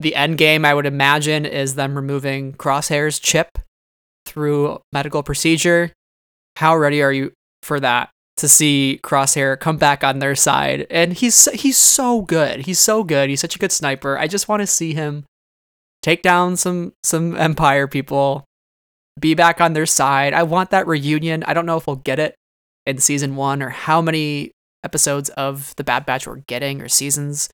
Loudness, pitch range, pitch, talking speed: -16 LUFS, 140-165 Hz, 145 Hz, 185 wpm